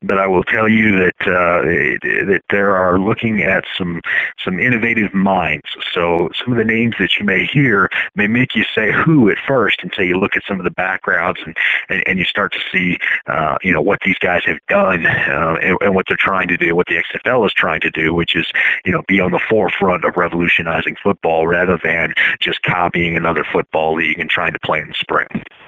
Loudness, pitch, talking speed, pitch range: -15 LUFS, 90 Hz, 220 wpm, 80-100 Hz